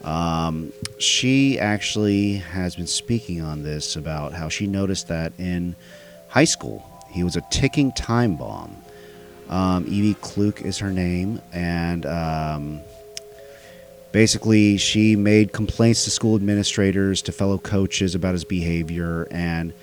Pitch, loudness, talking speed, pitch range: 95 Hz, -21 LUFS, 135 wpm, 85-105 Hz